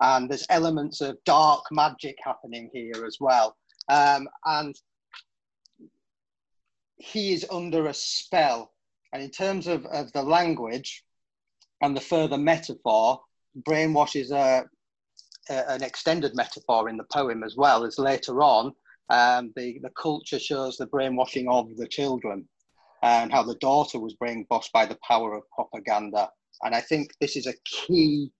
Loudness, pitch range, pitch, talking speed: -25 LUFS, 120-155 Hz, 140 Hz, 150 wpm